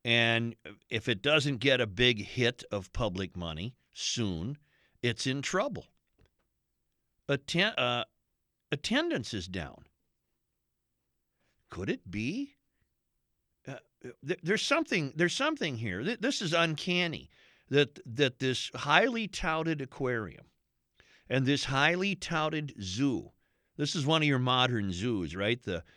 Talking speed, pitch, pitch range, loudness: 125 wpm, 130 Hz, 115-160 Hz, -30 LUFS